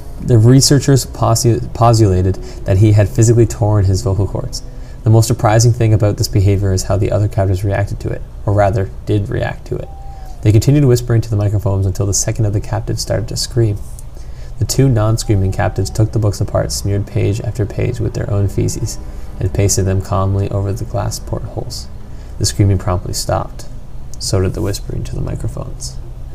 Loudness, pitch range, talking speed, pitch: -15 LUFS, 95-115 Hz, 190 wpm, 105 Hz